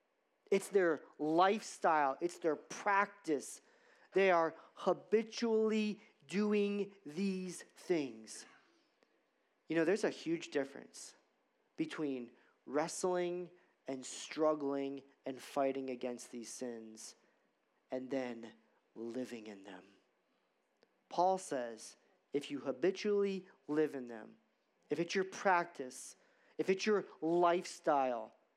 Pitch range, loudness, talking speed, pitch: 135-195 Hz, -37 LUFS, 100 wpm, 165 Hz